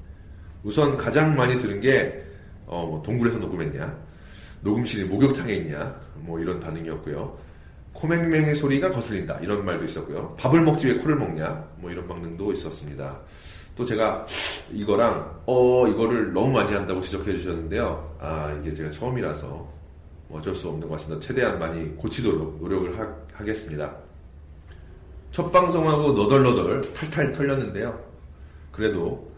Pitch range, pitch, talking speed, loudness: 80-120 Hz, 90 Hz, 320 characters per minute, -25 LUFS